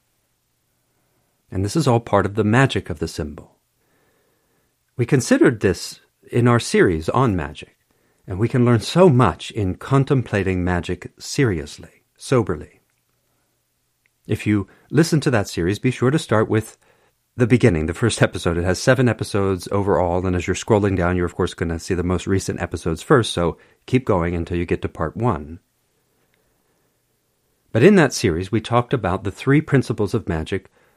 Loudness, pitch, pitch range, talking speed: -19 LUFS, 105 Hz, 90-125 Hz, 170 wpm